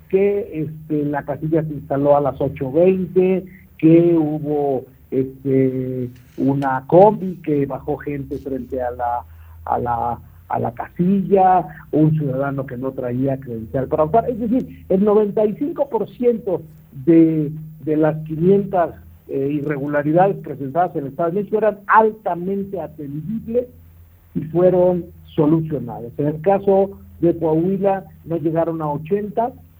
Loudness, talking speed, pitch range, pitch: -19 LUFS, 125 wpm, 135-185 Hz, 155 Hz